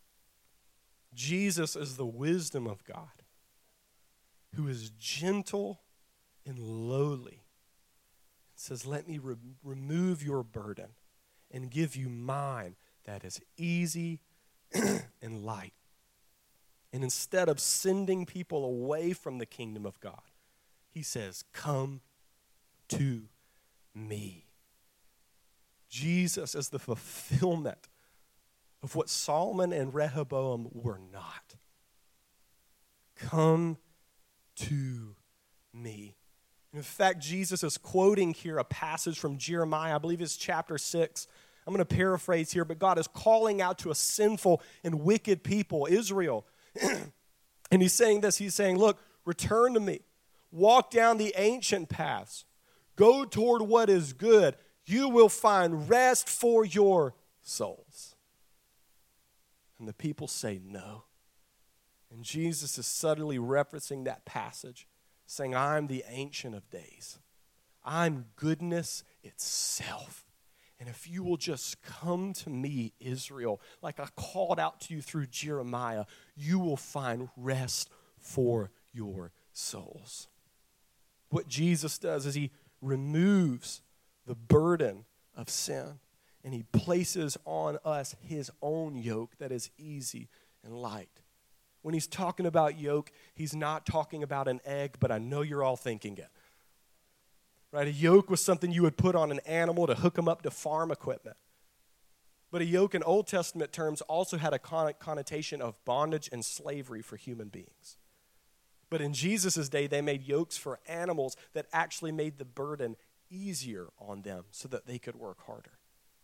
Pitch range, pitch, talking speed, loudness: 125-170 Hz, 150 Hz, 135 wpm, -31 LUFS